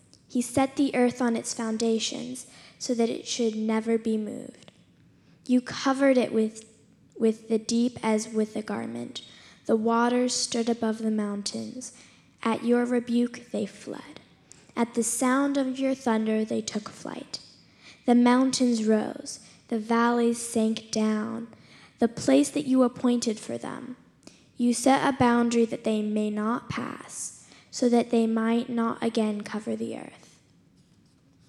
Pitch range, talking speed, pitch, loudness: 220-250 Hz, 145 wpm, 235 Hz, -26 LUFS